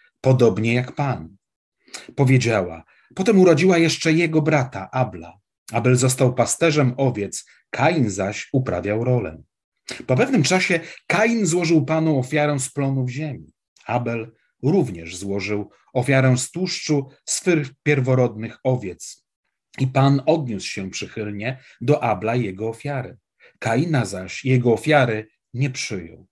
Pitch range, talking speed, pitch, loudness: 115-150 Hz, 120 wpm, 130 Hz, -21 LUFS